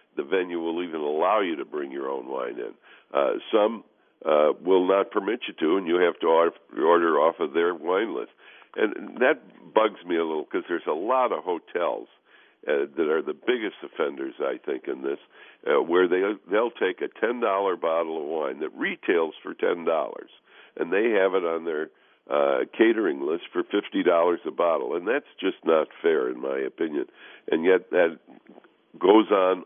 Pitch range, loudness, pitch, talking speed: 360-440 Hz, -25 LUFS, 400 Hz, 190 wpm